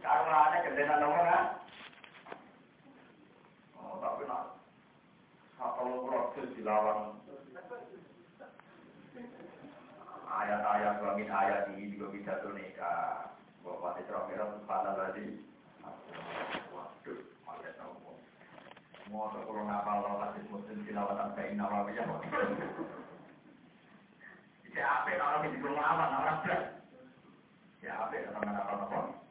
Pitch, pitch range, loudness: 105 Hz, 100-140 Hz, -35 LUFS